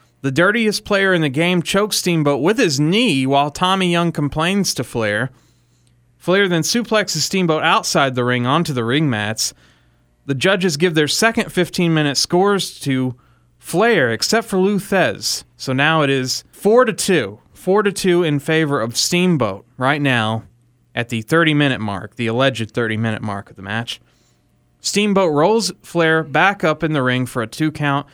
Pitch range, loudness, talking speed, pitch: 120-180 Hz, -17 LUFS, 175 wpm, 150 Hz